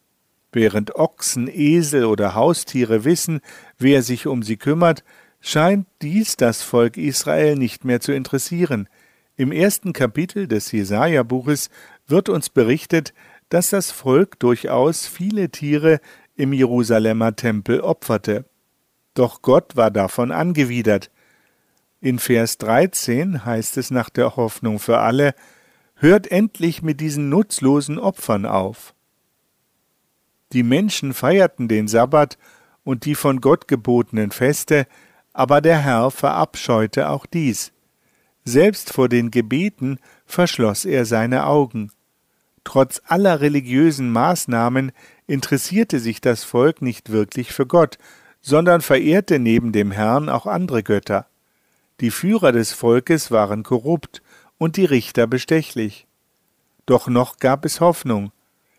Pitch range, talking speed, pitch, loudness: 115-160 Hz, 120 wpm, 130 Hz, -18 LUFS